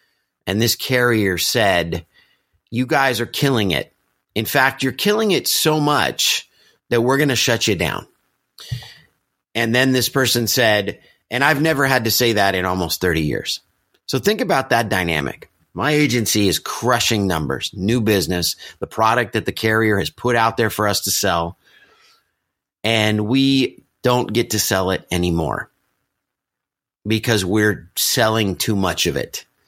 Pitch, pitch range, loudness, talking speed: 110 Hz, 95-125 Hz, -18 LUFS, 160 wpm